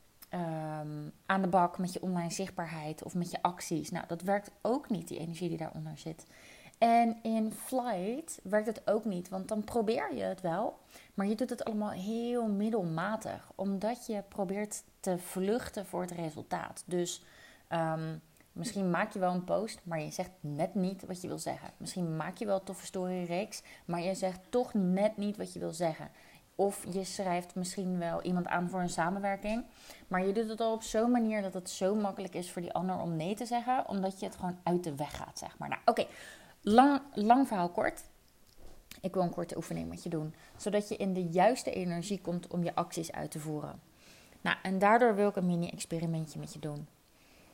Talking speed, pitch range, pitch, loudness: 205 wpm, 170-210 Hz, 185 Hz, -34 LUFS